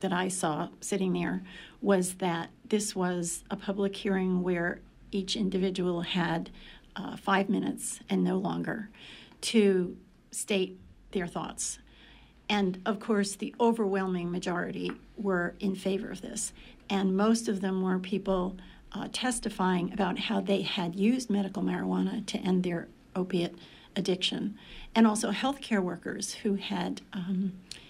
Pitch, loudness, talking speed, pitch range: 195 Hz, -31 LUFS, 140 wpm, 180-210 Hz